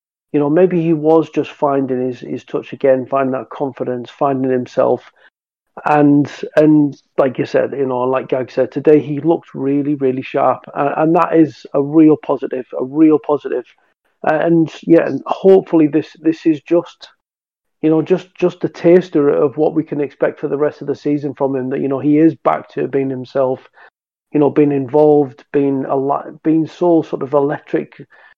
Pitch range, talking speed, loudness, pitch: 135-160 Hz, 190 wpm, -15 LUFS, 145 Hz